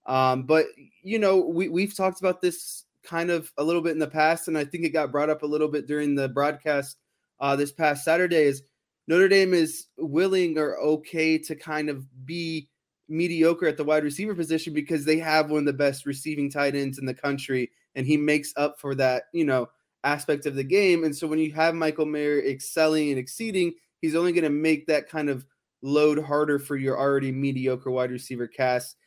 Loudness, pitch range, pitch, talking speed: -25 LUFS, 140-165 Hz, 150 Hz, 215 wpm